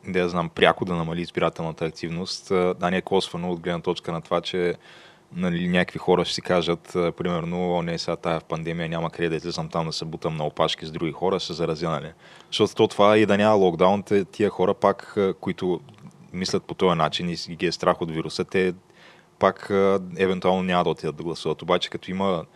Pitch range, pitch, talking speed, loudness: 85-95 Hz, 90 Hz, 205 wpm, -24 LUFS